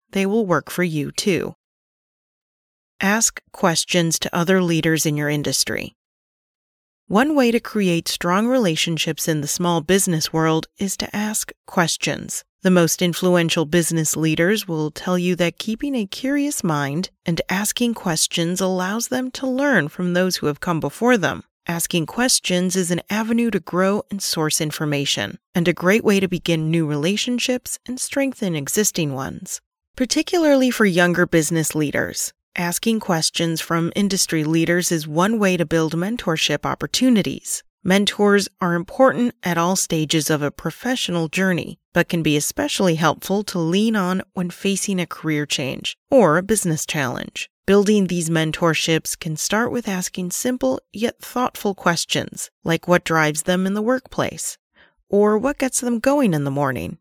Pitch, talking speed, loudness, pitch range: 180 Hz, 155 wpm, -20 LUFS, 160-215 Hz